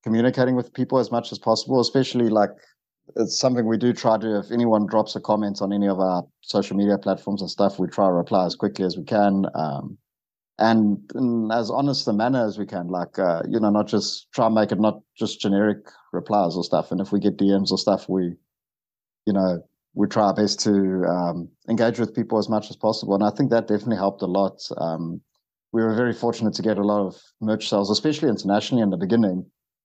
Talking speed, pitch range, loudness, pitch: 225 wpm, 95-115 Hz, -22 LUFS, 105 Hz